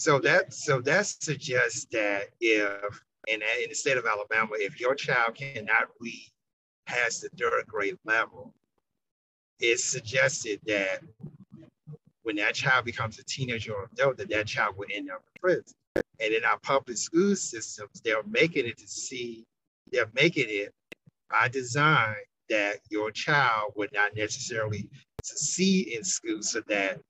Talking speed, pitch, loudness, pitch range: 155 wpm, 130 Hz, -27 LUFS, 110-185 Hz